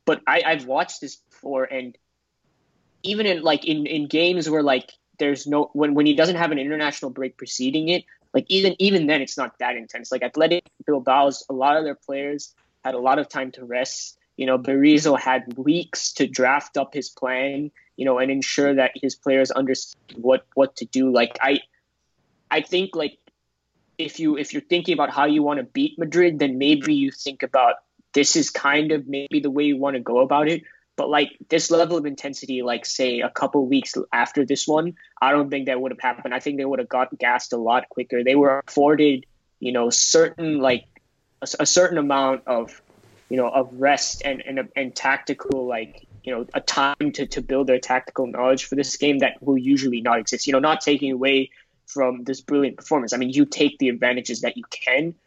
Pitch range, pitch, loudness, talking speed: 130-150 Hz, 140 Hz, -21 LUFS, 215 wpm